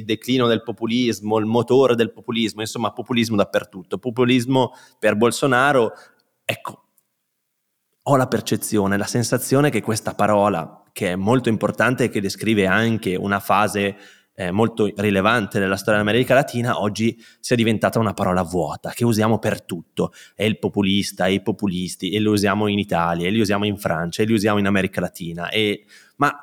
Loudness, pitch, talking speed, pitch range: -20 LUFS, 105 Hz, 165 wpm, 100-115 Hz